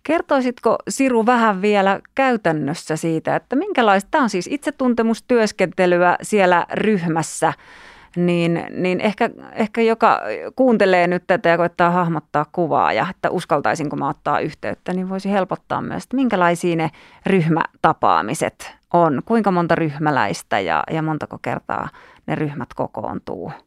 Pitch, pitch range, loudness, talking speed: 190 Hz, 170-230 Hz, -19 LUFS, 130 wpm